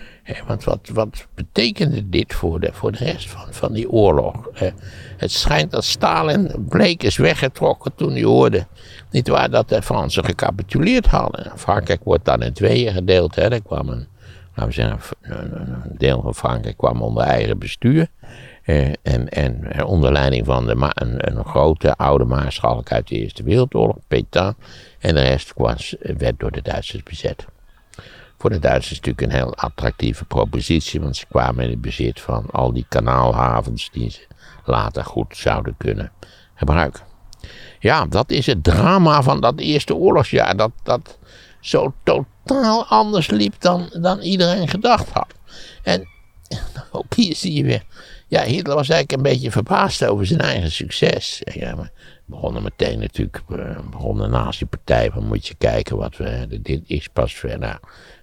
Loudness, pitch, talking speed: -19 LUFS, 95 Hz, 165 wpm